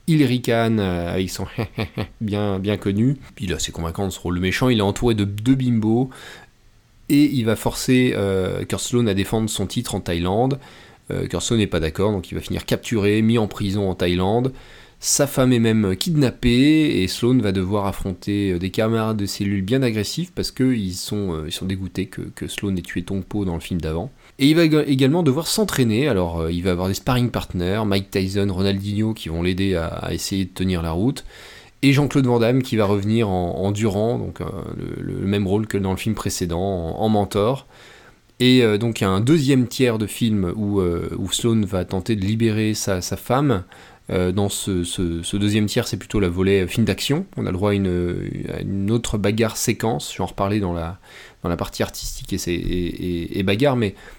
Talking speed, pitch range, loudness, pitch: 215 wpm, 95-120 Hz, -21 LUFS, 105 Hz